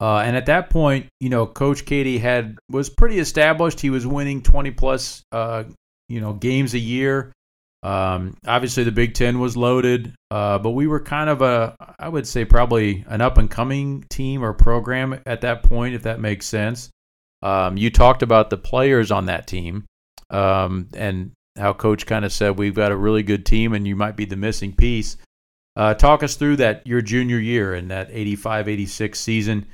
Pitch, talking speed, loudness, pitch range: 115 Hz, 200 wpm, -20 LUFS, 105-130 Hz